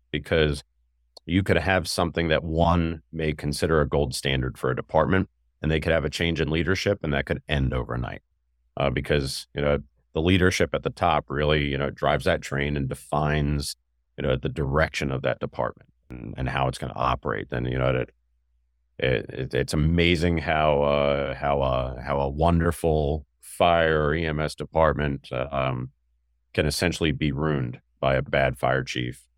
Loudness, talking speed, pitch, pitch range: -25 LUFS, 180 wpm, 75 Hz, 65-80 Hz